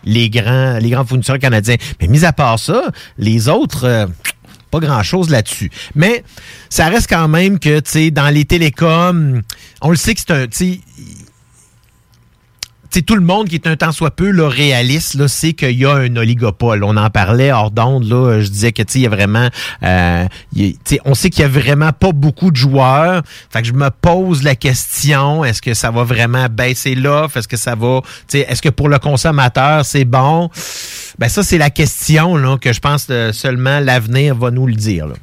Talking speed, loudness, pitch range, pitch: 210 wpm, -12 LUFS, 120-155 Hz, 135 Hz